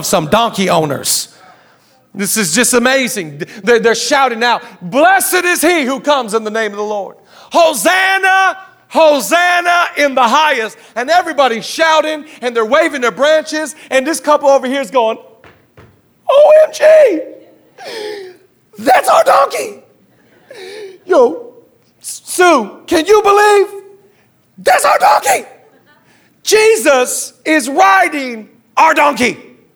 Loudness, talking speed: -11 LUFS, 120 wpm